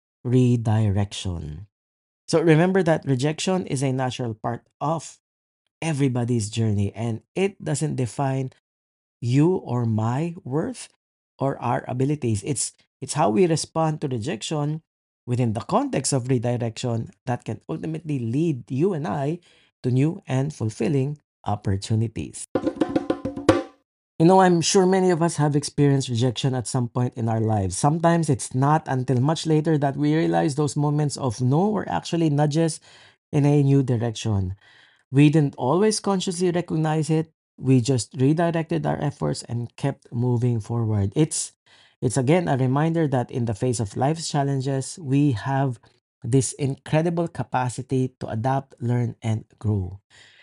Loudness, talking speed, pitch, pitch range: -23 LUFS, 145 wpm, 135 Hz, 120-155 Hz